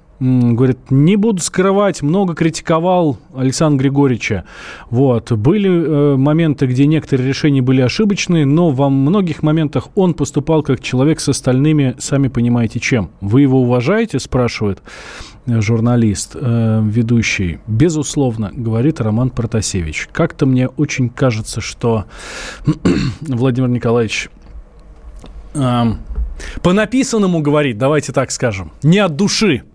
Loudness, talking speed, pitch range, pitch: -15 LUFS, 120 wpm, 115-155 Hz, 135 Hz